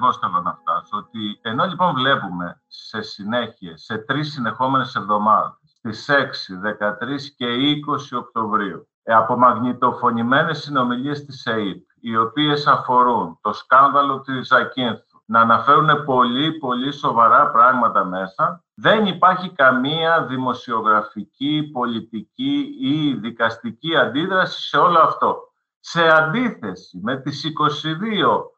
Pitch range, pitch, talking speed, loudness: 115-155 Hz, 135 Hz, 115 wpm, -18 LUFS